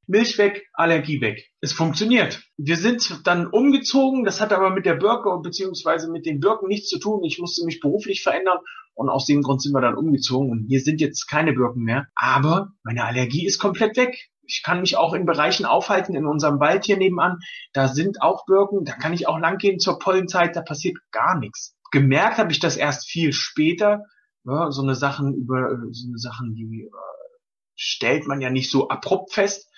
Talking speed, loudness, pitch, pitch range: 200 wpm, -21 LUFS, 165 Hz, 140-195 Hz